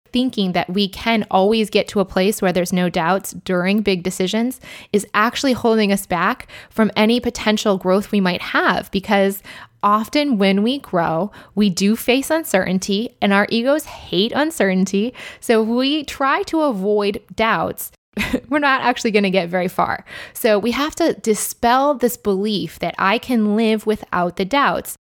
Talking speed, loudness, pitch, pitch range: 170 wpm, -18 LUFS, 210 Hz, 195-240 Hz